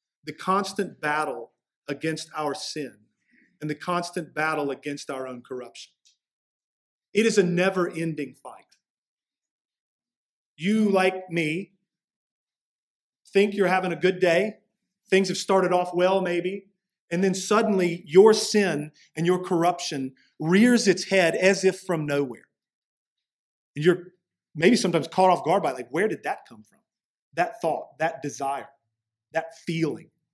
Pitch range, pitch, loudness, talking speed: 155-190 Hz, 175 Hz, -24 LUFS, 140 wpm